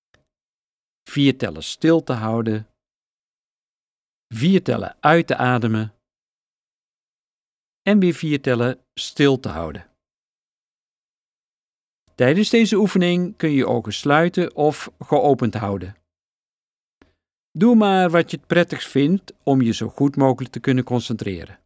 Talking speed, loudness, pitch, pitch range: 120 wpm, -19 LUFS, 135 Hz, 115-165 Hz